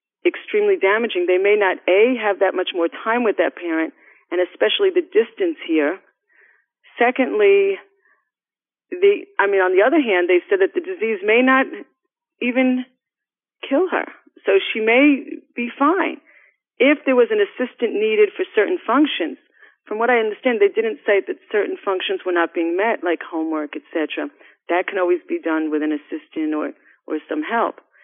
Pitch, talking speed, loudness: 255 Hz, 170 wpm, -19 LUFS